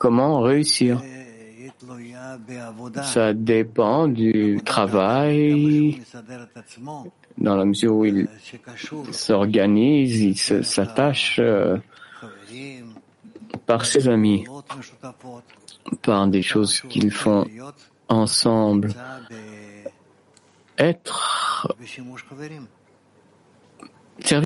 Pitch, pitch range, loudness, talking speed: 120 Hz, 105-130 Hz, -20 LUFS, 60 wpm